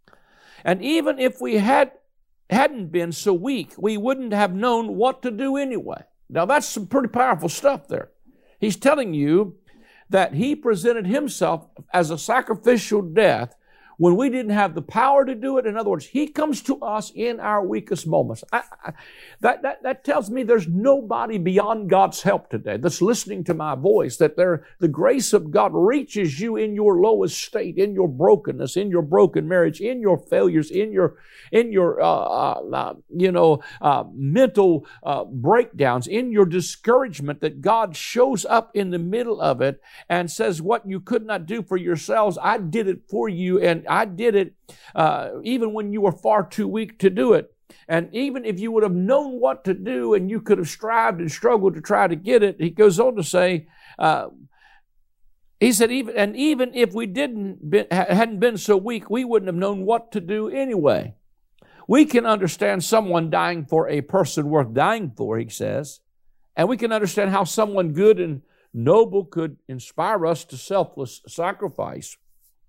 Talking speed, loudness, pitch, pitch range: 185 wpm, -21 LUFS, 205 Hz, 175-235 Hz